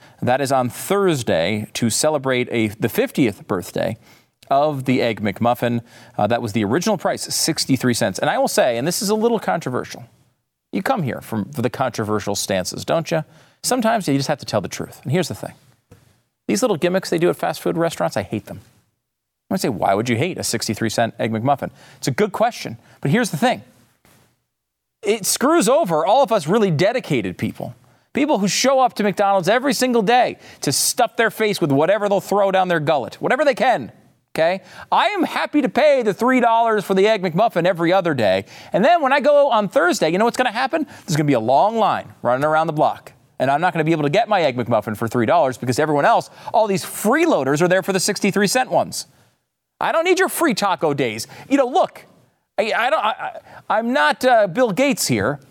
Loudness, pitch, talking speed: -19 LUFS, 180 Hz, 220 wpm